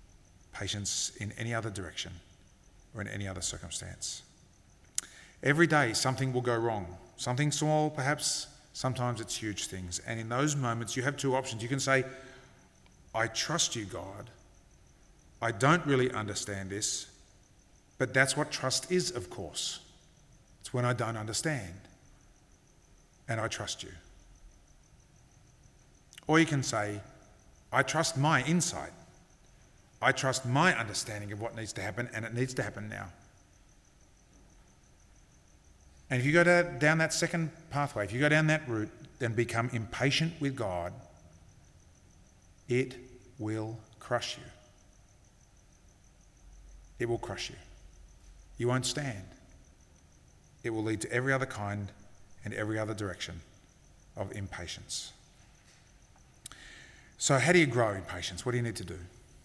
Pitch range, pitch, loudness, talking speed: 95-130 Hz, 115 Hz, -31 LUFS, 140 wpm